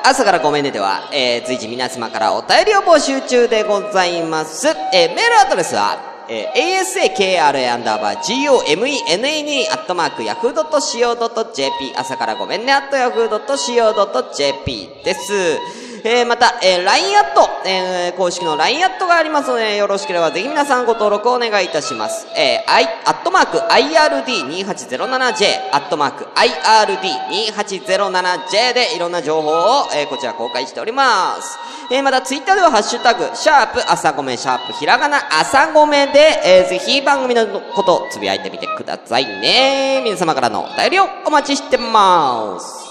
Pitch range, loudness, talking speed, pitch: 185-305 Hz, -15 LUFS, 390 characters per minute, 245 Hz